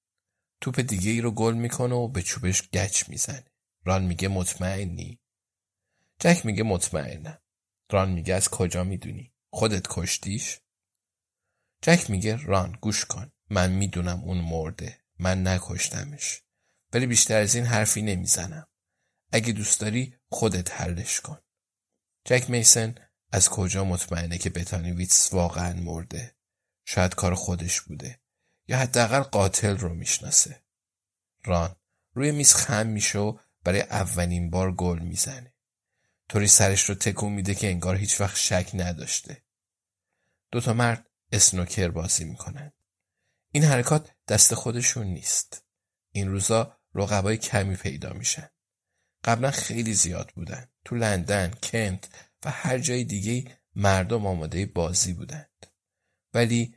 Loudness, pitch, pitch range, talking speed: -24 LUFS, 100 Hz, 90-115 Hz, 125 wpm